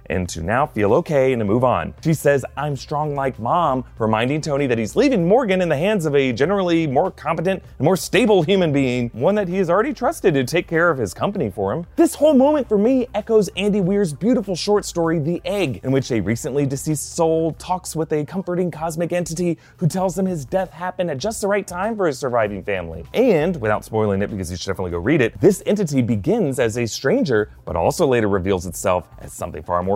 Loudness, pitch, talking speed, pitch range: -20 LUFS, 160 Hz, 230 wpm, 125-190 Hz